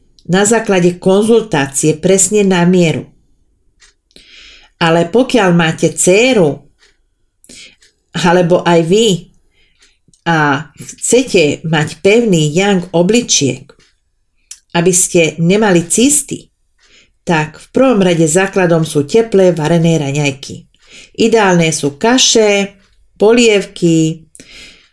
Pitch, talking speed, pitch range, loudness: 180 Hz, 85 wpm, 165-205 Hz, -11 LUFS